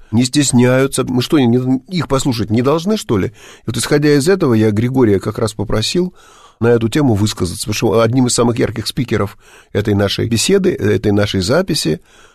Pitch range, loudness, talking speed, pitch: 110-145 Hz, -15 LUFS, 180 wpm, 125 Hz